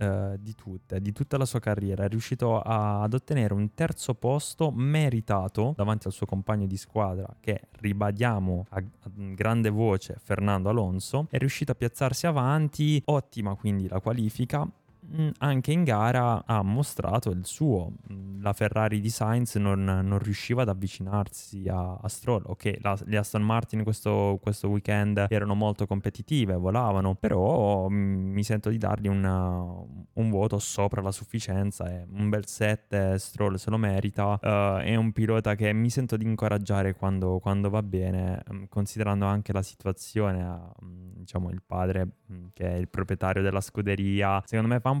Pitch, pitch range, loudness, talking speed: 105 Hz, 95-115 Hz, -28 LUFS, 160 wpm